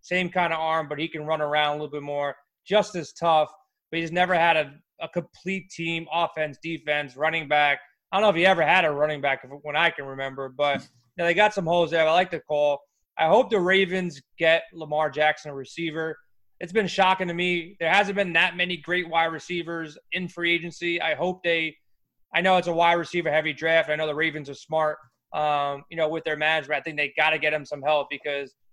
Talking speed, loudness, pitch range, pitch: 235 wpm, -24 LUFS, 150-175 Hz, 160 Hz